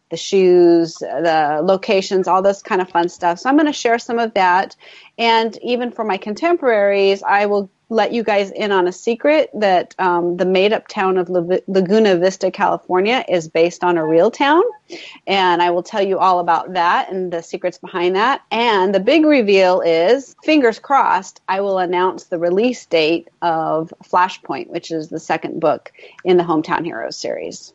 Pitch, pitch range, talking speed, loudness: 190 Hz, 175-220 Hz, 190 wpm, -16 LUFS